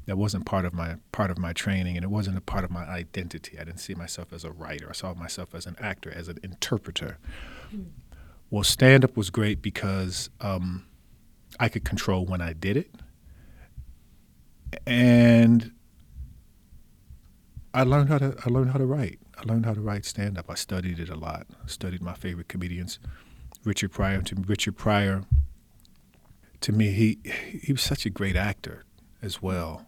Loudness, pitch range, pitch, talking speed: -26 LUFS, 85-110 Hz, 95 Hz, 175 wpm